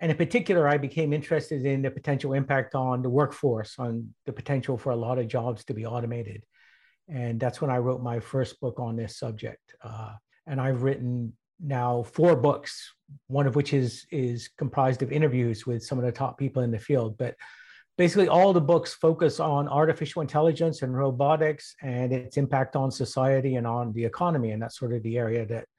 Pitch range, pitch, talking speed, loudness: 120-145 Hz, 130 Hz, 200 wpm, -27 LUFS